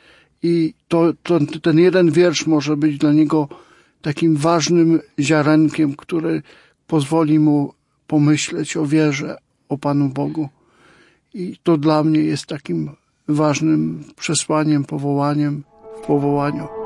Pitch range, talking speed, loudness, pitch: 145-165 Hz, 120 wpm, -18 LUFS, 155 Hz